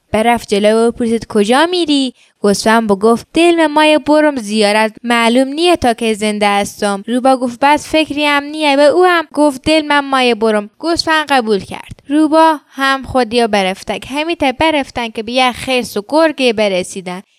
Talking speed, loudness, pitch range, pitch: 165 wpm, -13 LUFS, 220-300 Hz, 255 Hz